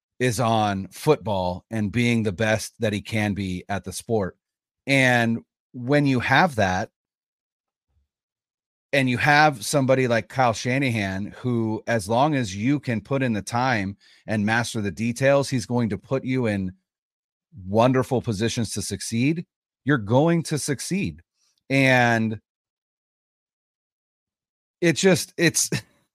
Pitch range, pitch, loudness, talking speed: 105-135 Hz, 115 Hz, -23 LUFS, 135 wpm